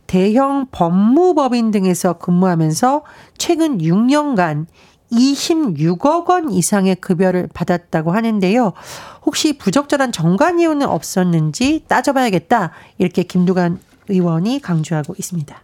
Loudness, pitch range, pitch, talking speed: -16 LUFS, 175-275 Hz, 195 Hz, 275 characters per minute